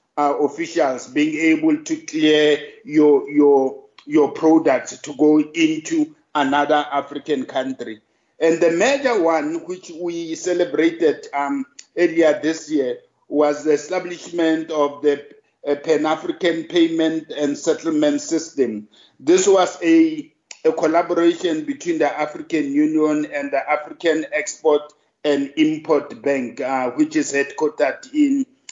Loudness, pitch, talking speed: -19 LUFS, 155 Hz, 125 wpm